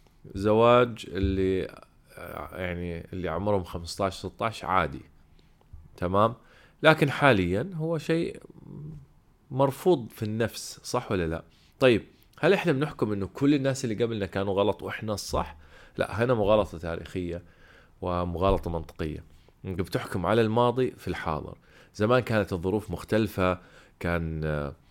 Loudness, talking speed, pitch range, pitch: -27 LUFS, 120 wpm, 85-120 Hz, 100 Hz